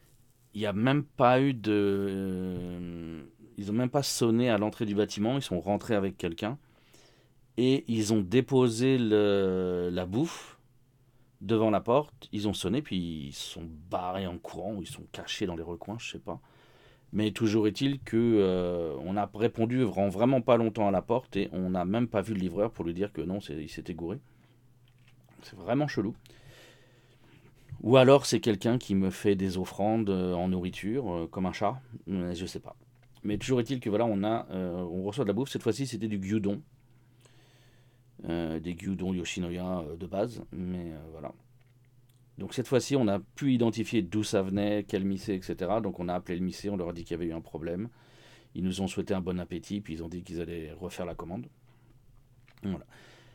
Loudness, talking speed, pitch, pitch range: -30 LUFS, 200 wpm, 105 Hz, 90-125 Hz